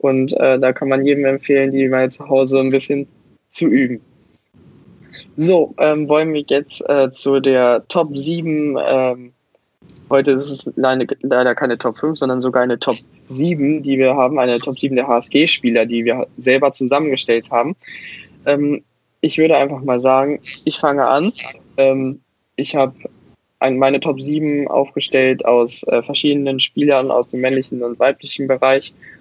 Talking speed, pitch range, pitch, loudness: 160 wpm, 130-145 Hz, 135 Hz, -16 LUFS